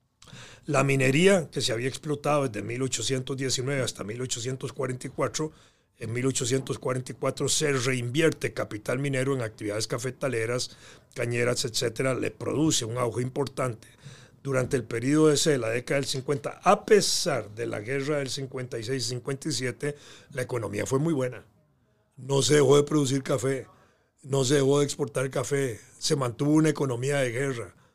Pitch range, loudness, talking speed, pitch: 125-140 Hz, -27 LUFS, 135 wpm, 135 Hz